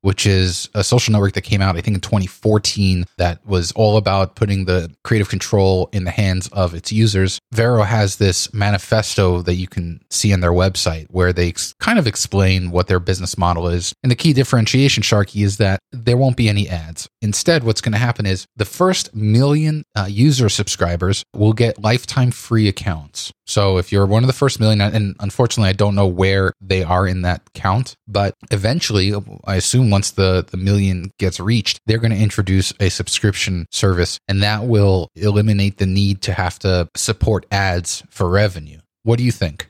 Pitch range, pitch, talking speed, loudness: 95-110 Hz, 100 Hz, 195 wpm, -17 LUFS